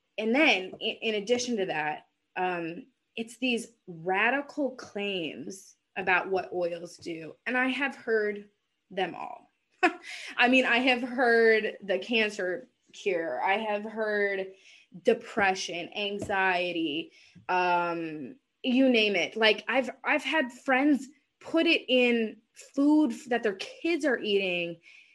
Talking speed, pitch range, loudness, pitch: 125 wpm, 190-260 Hz, -27 LUFS, 225 Hz